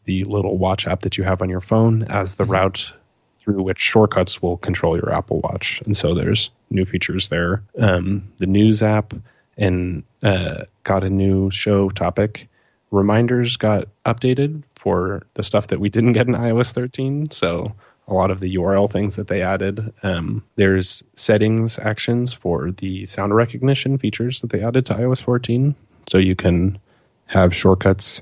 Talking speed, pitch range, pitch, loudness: 170 wpm, 95-115 Hz, 100 Hz, -19 LUFS